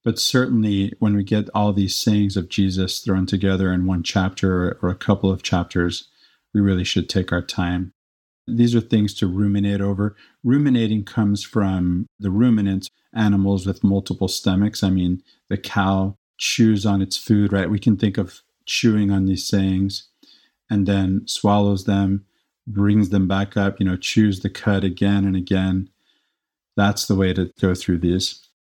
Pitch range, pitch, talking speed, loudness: 95-105 Hz, 100 Hz, 170 wpm, -20 LUFS